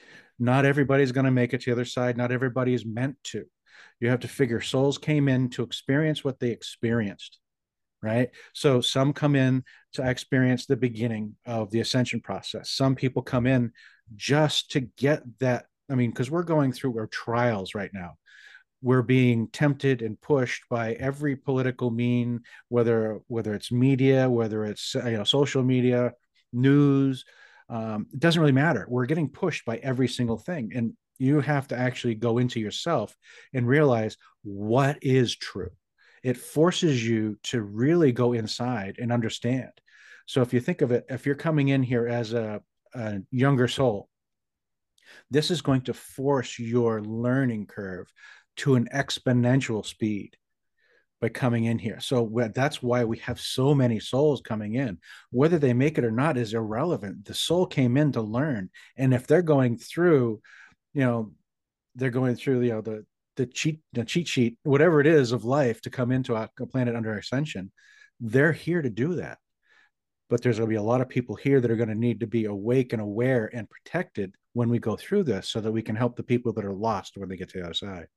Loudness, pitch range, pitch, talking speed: -26 LUFS, 115-135 Hz, 125 Hz, 190 wpm